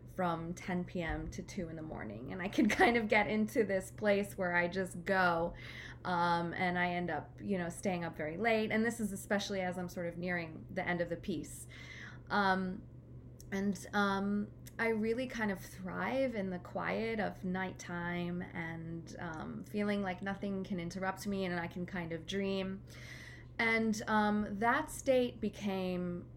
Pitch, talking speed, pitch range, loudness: 185 Hz, 180 wpm, 175-205 Hz, -36 LUFS